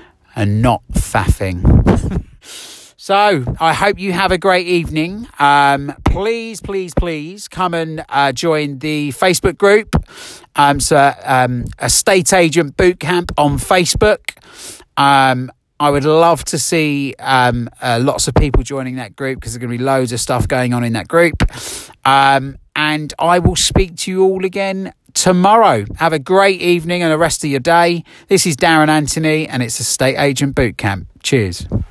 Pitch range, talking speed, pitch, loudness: 130-175 Hz, 165 wpm, 150 Hz, -14 LUFS